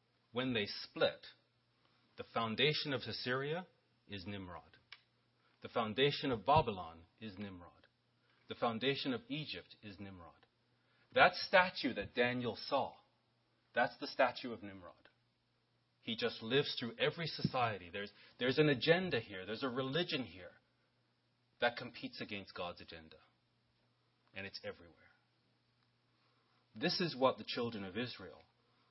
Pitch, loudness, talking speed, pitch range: 120 Hz, -37 LUFS, 125 wpm, 100-140 Hz